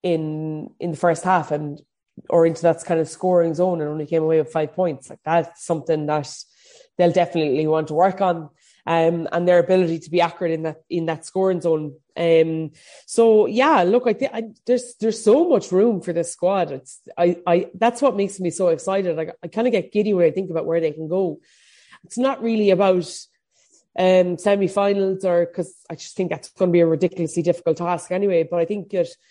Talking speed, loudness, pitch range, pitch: 215 wpm, -20 LUFS, 165-190 Hz, 175 Hz